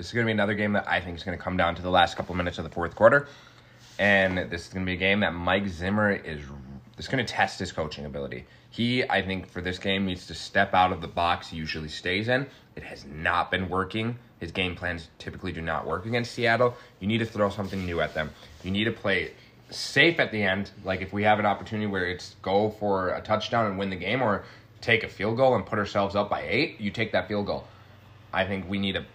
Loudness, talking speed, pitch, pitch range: -26 LUFS, 265 wpm, 100 Hz, 90-110 Hz